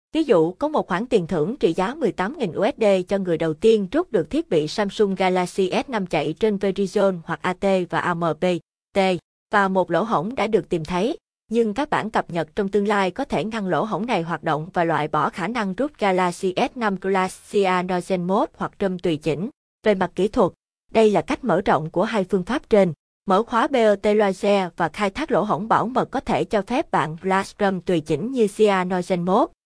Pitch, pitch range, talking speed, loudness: 195 Hz, 180-220 Hz, 210 wpm, -22 LUFS